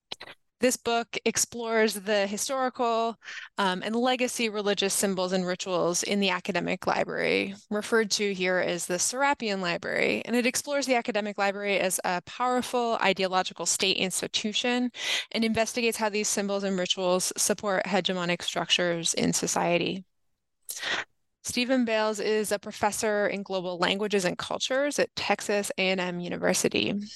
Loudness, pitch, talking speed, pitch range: -27 LUFS, 205 Hz, 135 wpm, 190-230 Hz